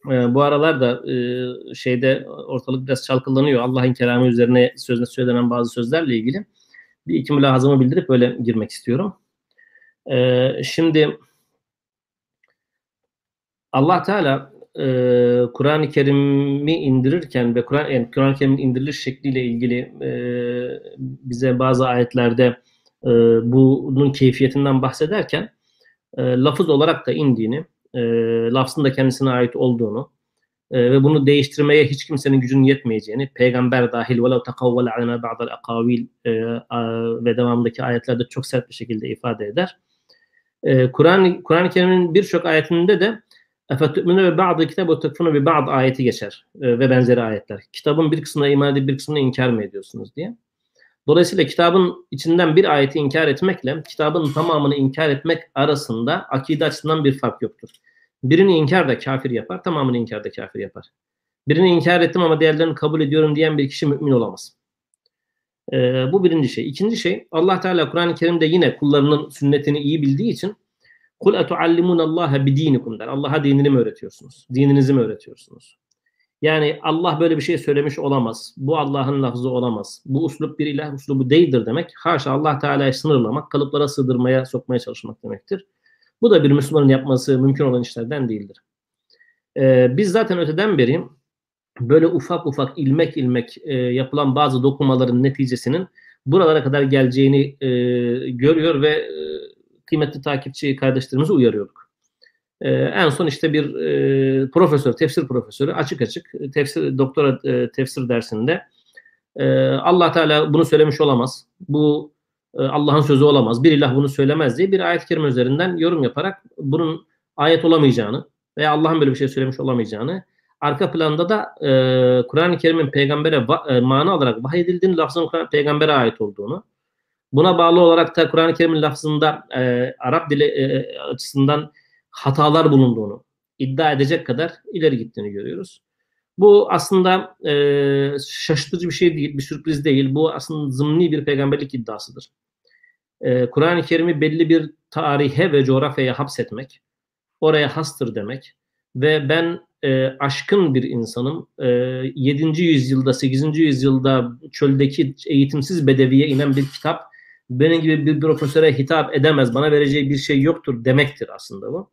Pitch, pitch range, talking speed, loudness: 140 Hz, 130-160 Hz, 140 wpm, -18 LUFS